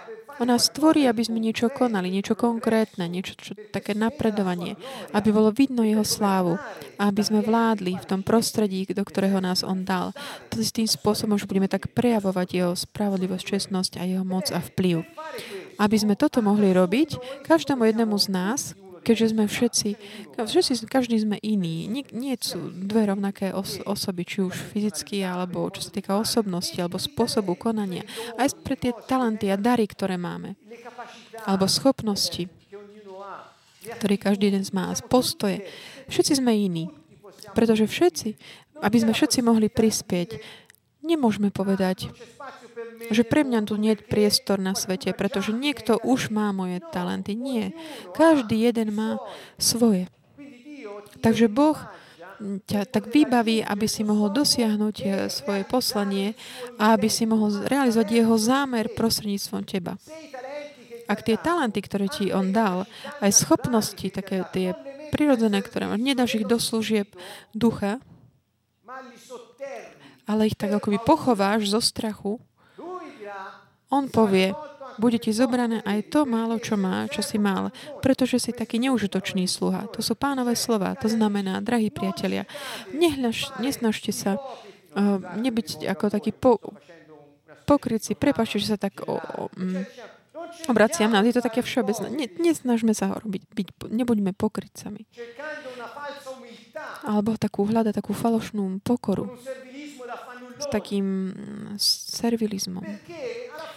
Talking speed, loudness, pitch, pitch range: 135 wpm, -24 LUFS, 215 Hz, 195-240 Hz